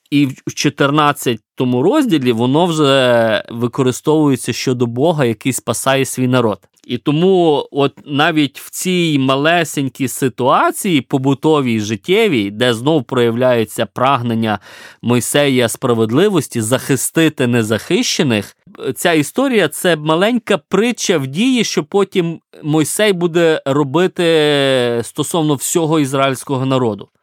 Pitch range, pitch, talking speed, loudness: 125-160 Hz, 140 Hz, 105 wpm, -15 LUFS